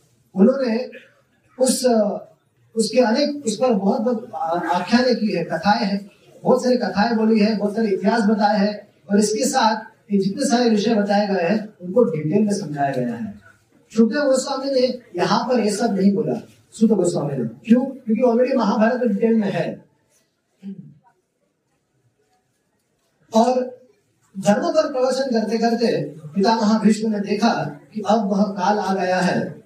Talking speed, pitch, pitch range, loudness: 150 wpm, 220 Hz, 200-240 Hz, -20 LUFS